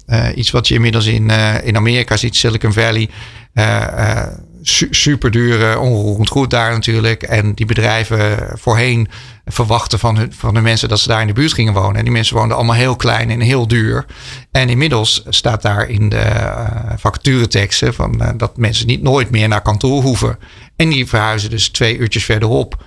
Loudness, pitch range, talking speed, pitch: -13 LUFS, 110-120 Hz, 195 wpm, 115 Hz